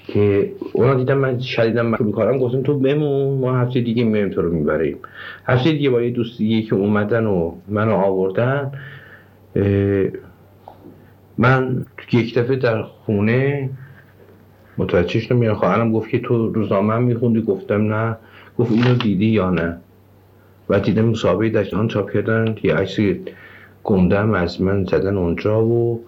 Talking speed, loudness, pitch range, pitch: 145 wpm, -19 LUFS, 100-125 Hz, 110 Hz